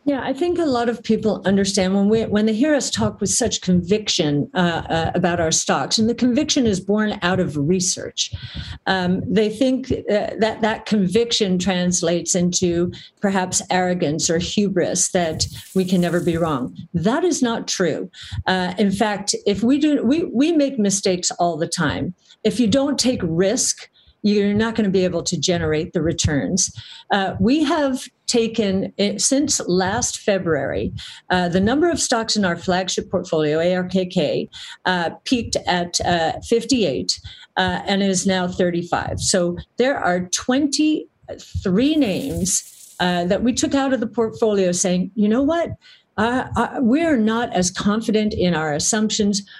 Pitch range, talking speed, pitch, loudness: 180-235 Hz, 165 wpm, 200 Hz, -20 LUFS